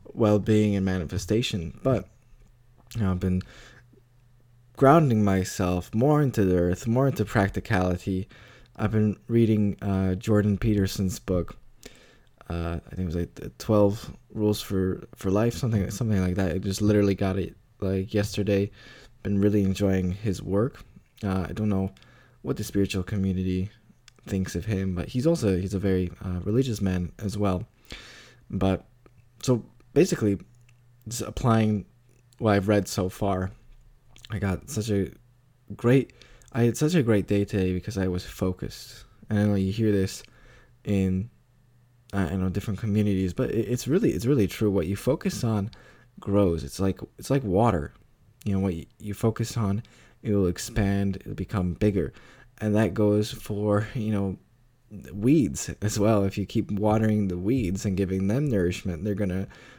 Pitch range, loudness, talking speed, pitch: 95-120 Hz, -26 LUFS, 165 wpm, 105 Hz